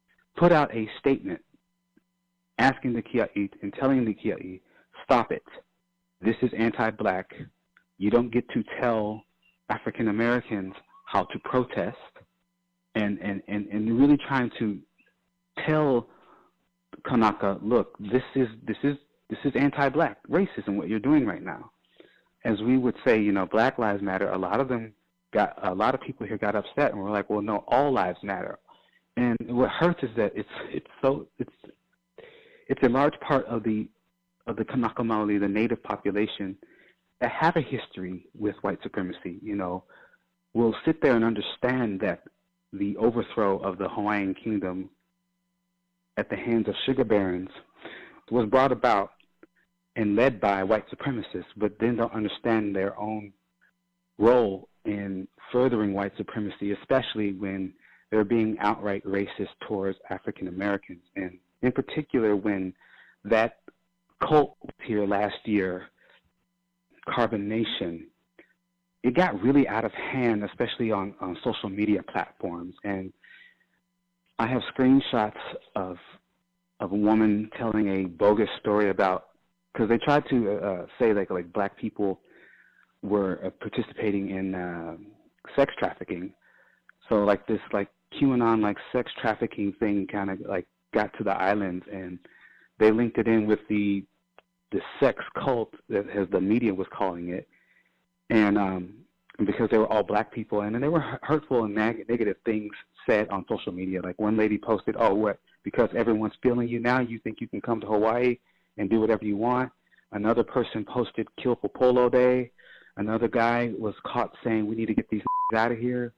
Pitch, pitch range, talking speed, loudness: 105 Hz, 95-120 Hz, 155 wpm, -27 LUFS